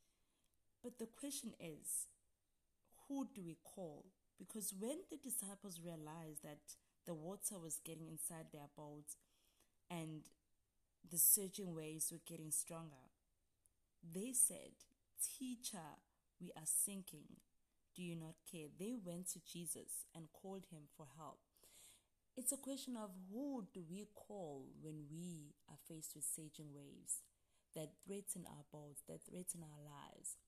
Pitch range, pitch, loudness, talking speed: 150-195 Hz, 165 Hz, -46 LUFS, 140 wpm